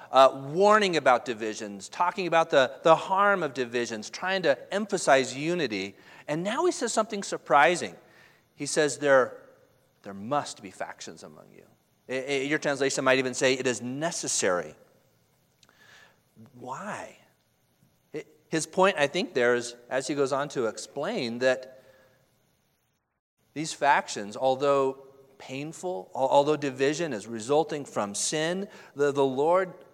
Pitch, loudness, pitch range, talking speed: 145 Hz, -26 LUFS, 130-170 Hz, 135 wpm